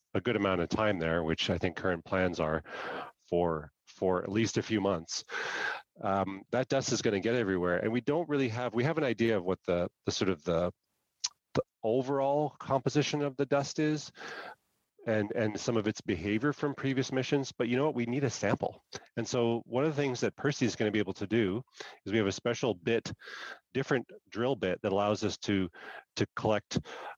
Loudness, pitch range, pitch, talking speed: -32 LUFS, 95-135 Hz, 115 Hz, 215 wpm